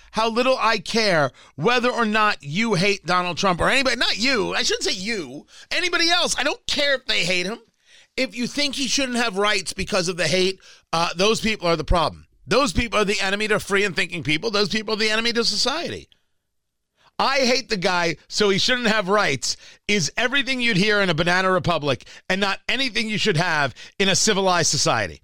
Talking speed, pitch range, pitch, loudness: 210 wpm, 180-235 Hz, 205 Hz, -20 LUFS